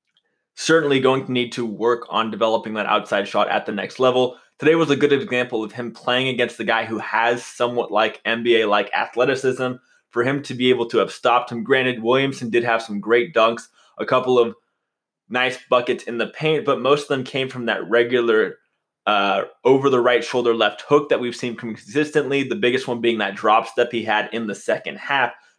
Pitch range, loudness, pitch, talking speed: 115-130 Hz, -20 LUFS, 125 Hz, 210 wpm